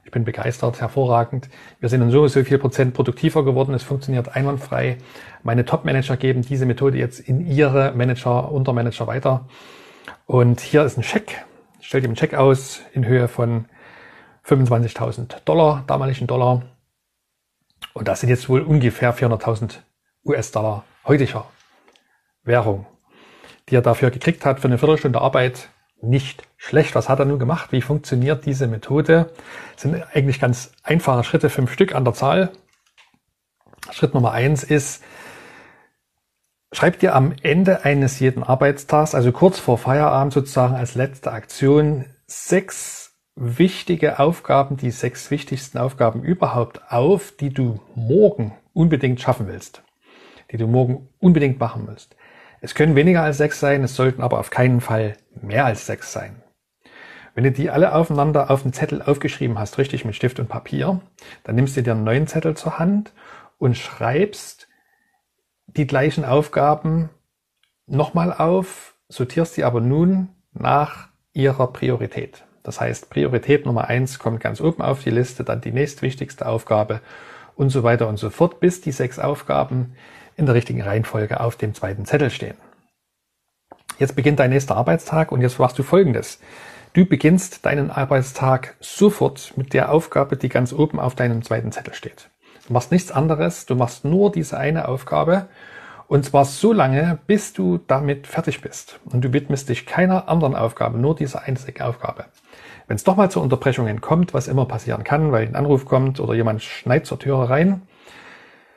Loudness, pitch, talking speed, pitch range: -19 LUFS, 135 Hz, 160 wpm, 120-150 Hz